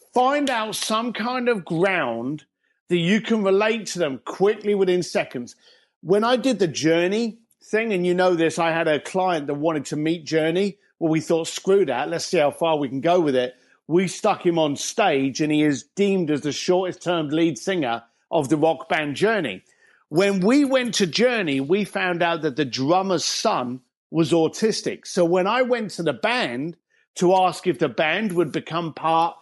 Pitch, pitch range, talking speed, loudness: 175 Hz, 155-200 Hz, 200 wpm, -22 LUFS